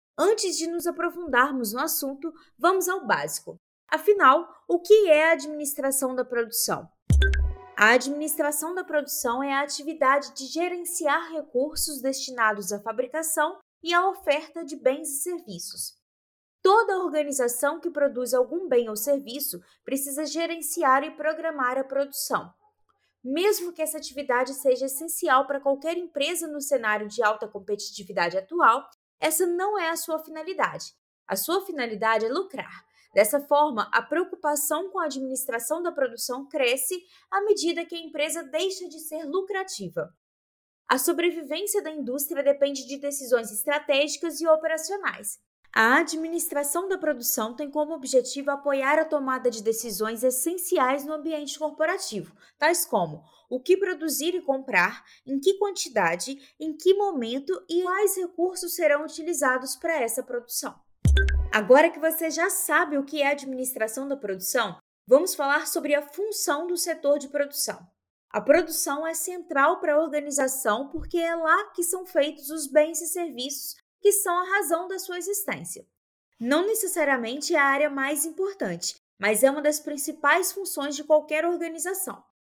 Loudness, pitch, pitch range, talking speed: -25 LUFS, 300 Hz, 265-335 Hz, 150 wpm